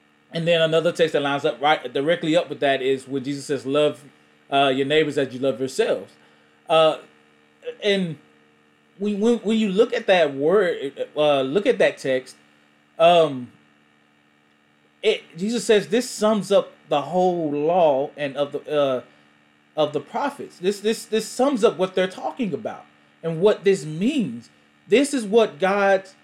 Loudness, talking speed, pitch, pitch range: -21 LUFS, 165 wpm, 155 Hz, 130-205 Hz